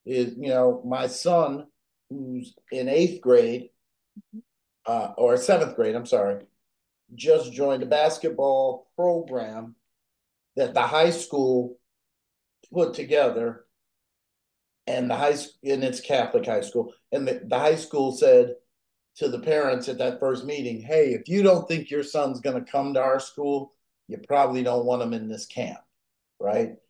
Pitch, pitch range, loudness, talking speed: 135 Hz, 125-160 Hz, -24 LUFS, 155 wpm